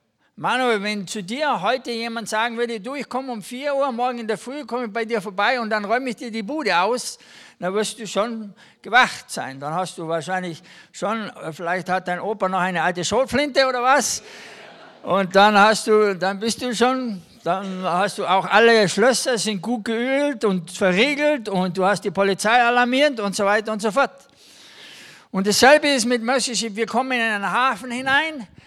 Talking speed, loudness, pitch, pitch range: 195 wpm, -20 LUFS, 225 Hz, 195-250 Hz